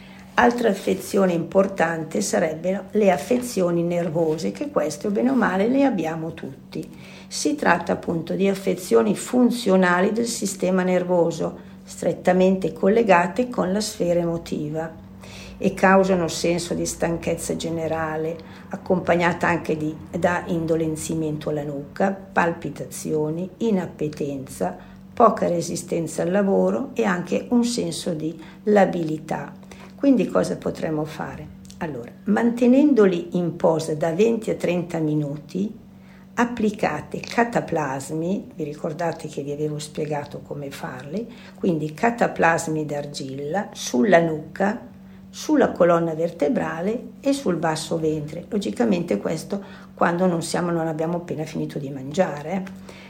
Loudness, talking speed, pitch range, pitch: -22 LUFS, 120 wpm, 160-195 Hz, 175 Hz